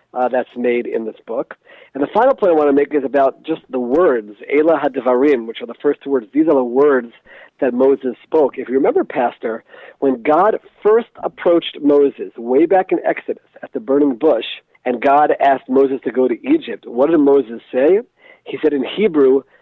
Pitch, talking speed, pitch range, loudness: 140 Hz, 205 wpm, 130-165 Hz, -16 LUFS